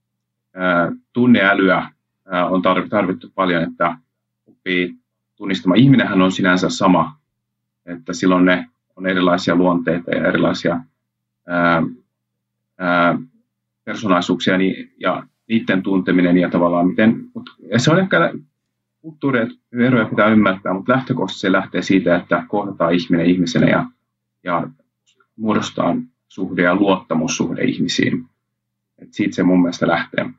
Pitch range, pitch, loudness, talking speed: 85-100 Hz, 90 Hz, -17 LUFS, 115 wpm